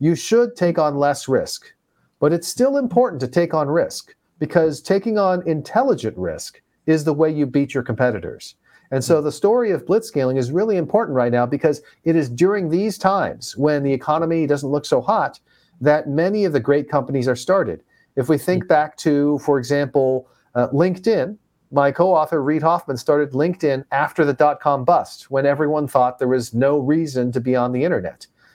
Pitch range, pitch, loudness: 135-170 Hz, 150 Hz, -19 LUFS